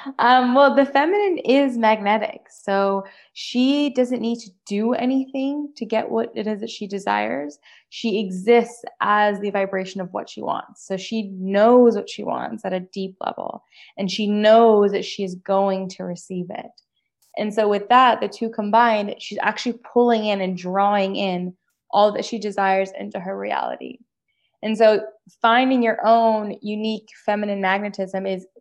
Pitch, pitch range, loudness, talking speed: 210 Hz, 195-235 Hz, -20 LUFS, 170 wpm